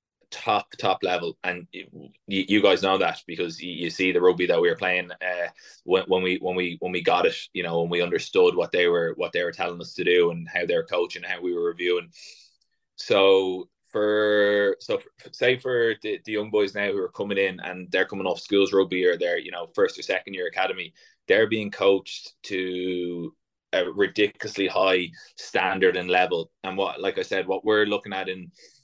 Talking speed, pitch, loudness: 210 wpm, 105 Hz, -24 LUFS